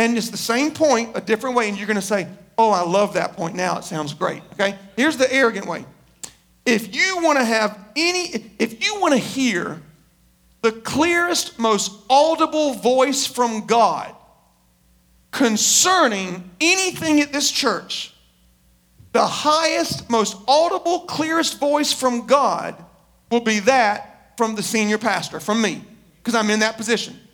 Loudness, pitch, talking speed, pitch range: -19 LUFS, 225 Hz, 160 wpm, 205-285 Hz